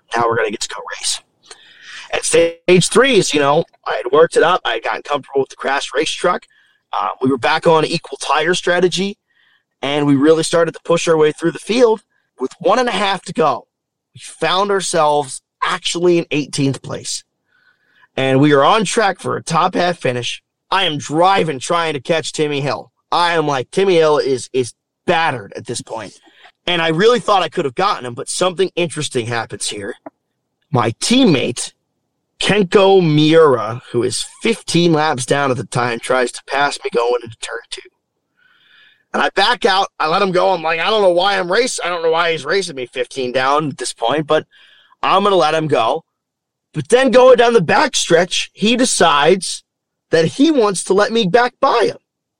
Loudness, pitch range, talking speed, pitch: -15 LUFS, 145-210 Hz, 205 wpm, 170 Hz